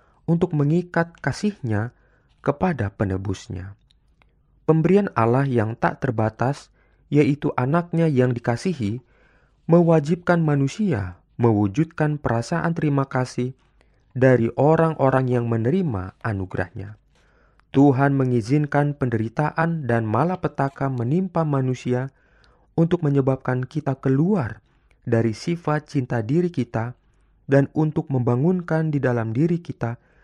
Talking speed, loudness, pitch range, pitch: 95 wpm, -22 LUFS, 120-160 Hz, 135 Hz